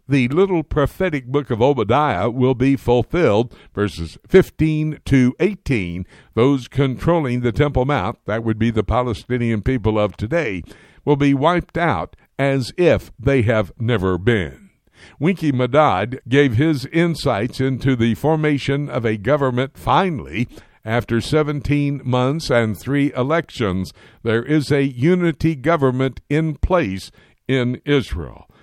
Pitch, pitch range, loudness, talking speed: 130 Hz, 115-145 Hz, -19 LUFS, 130 wpm